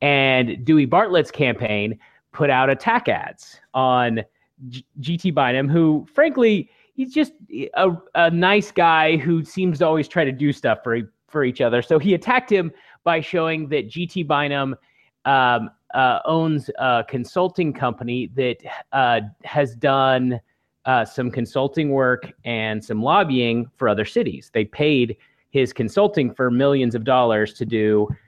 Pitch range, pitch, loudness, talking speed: 125-165 Hz, 140 Hz, -20 LUFS, 150 wpm